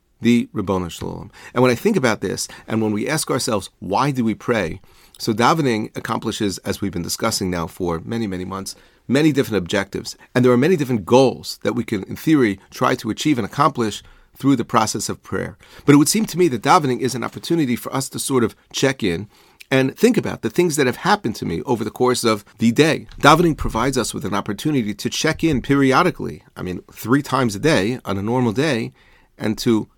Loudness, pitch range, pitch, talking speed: -19 LUFS, 105-135 Hz, 120 Hz, 220 wpm